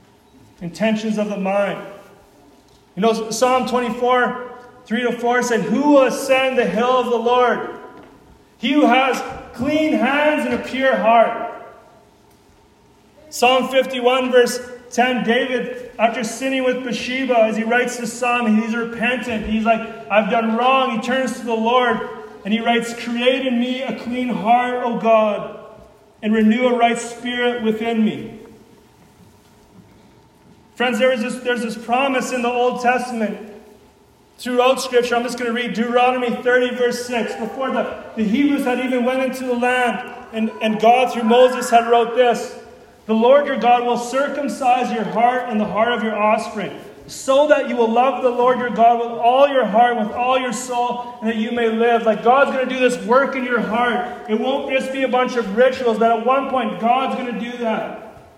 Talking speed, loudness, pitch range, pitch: 180 wpm, -18 LUFS, 230-250 Hz, 240 Hz